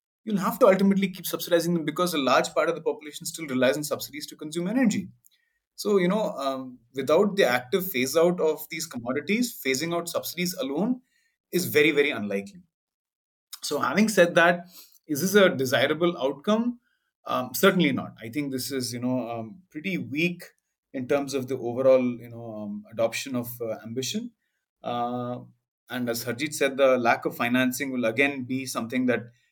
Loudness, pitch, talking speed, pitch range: -25 LUFS, 150 Hz, 175 wpm, 125-180 Hz